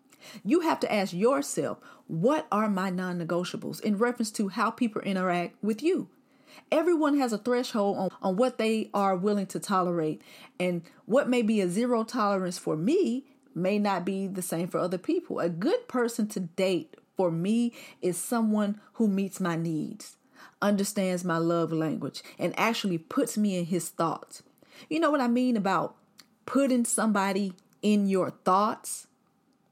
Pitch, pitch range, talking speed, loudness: 205 Hz, 185-245 Hz, 165 wpm, -28 LUFS